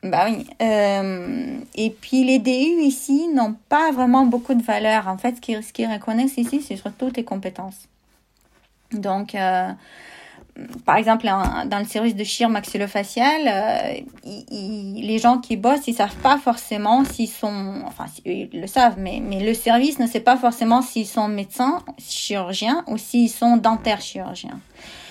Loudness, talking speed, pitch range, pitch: -20 LUFS, 165 wpm, 210-255 Hz, 230 Hz